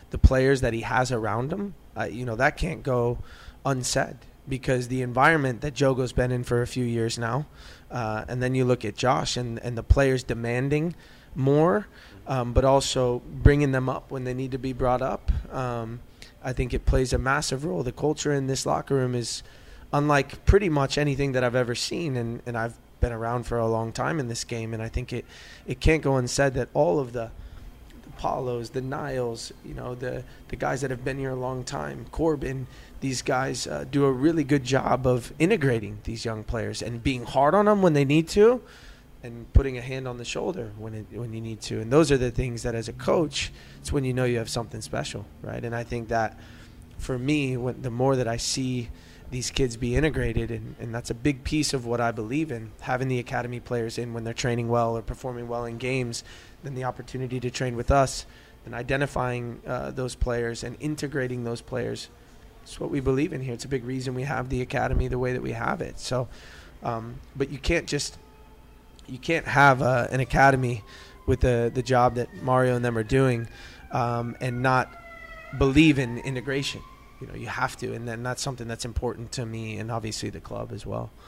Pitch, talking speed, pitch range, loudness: 125 Hz, 215 wpm, 115-135 Hz, -26 LUFS